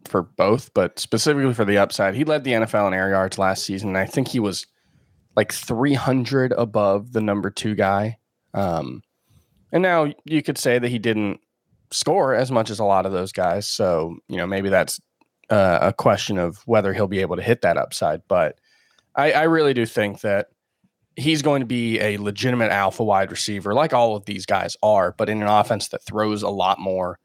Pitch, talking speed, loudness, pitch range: 105 Hz, 205 wpm, -21 LUFS, 100-120 Hz